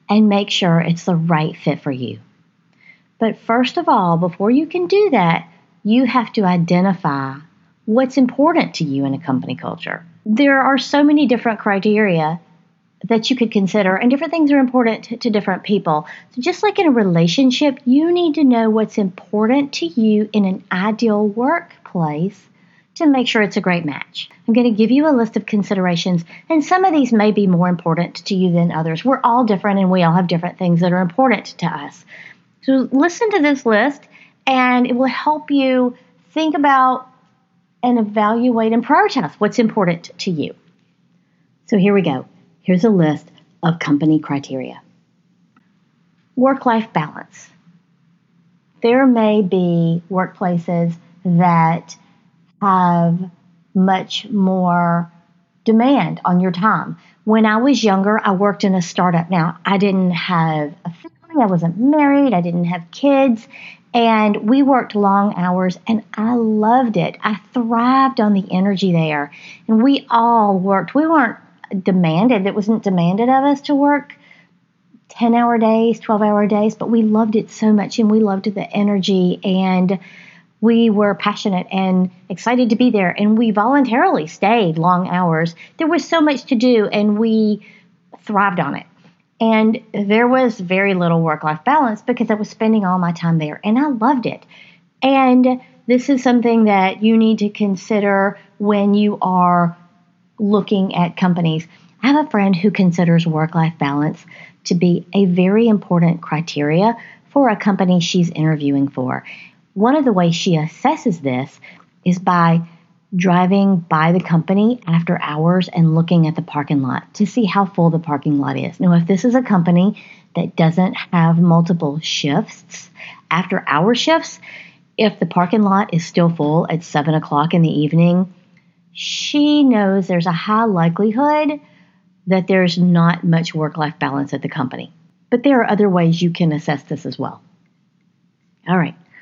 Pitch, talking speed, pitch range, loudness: 195 Hz, 170 wpm, 175-230 Hz, -16 LUFS